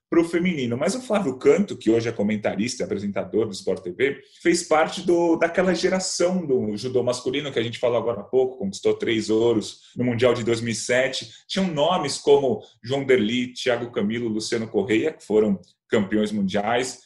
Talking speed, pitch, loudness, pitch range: 180 wpm, 125 Hz, -23 LUFS, 115-175 Hz